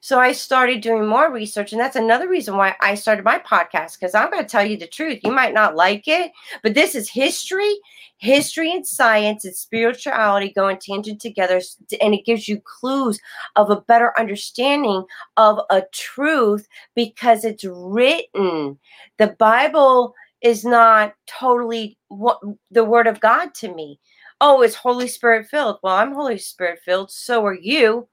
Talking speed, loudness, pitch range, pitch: 170 wpm, -18 LUFS, 205-255 Hz, 225 Hz